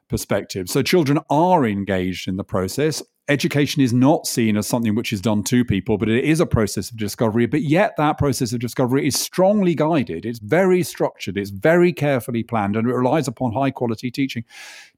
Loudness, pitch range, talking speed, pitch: -20 LUFS, 110-150 Hz, 195 wpm, 125 Hz